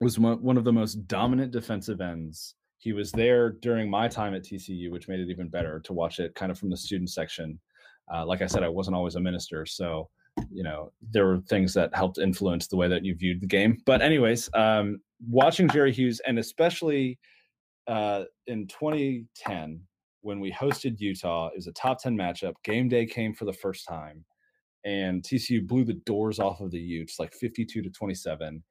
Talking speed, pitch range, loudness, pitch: 200 wpm, 90-115 Hz, -28 LUFS, 100 Hz